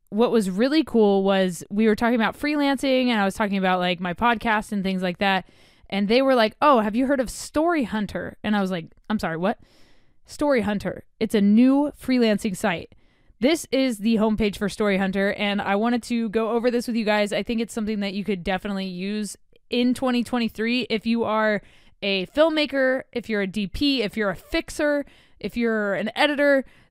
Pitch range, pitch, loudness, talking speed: 200-250 Hz, 220 Hz, -23 LUFS, 205 wpm